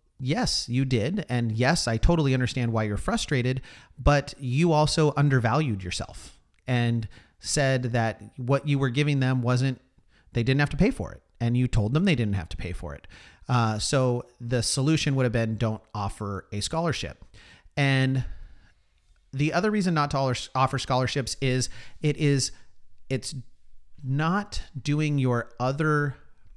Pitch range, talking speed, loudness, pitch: 110-145 Hz, 160 wpm, -26 LUFS, 125 Hz